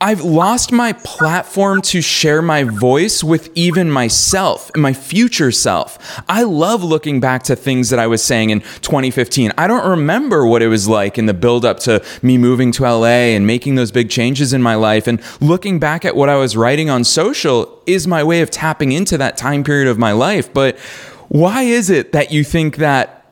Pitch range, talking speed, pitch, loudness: 120-170 Hz, 210 wpm, 140 Hz, -13 LUFS